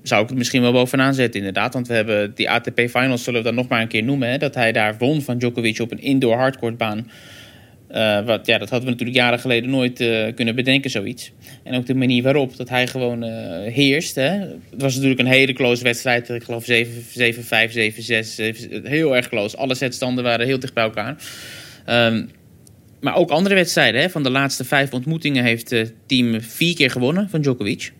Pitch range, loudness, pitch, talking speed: 115-135 Hz, -19 LUFS, 125 Hz, 210 wpm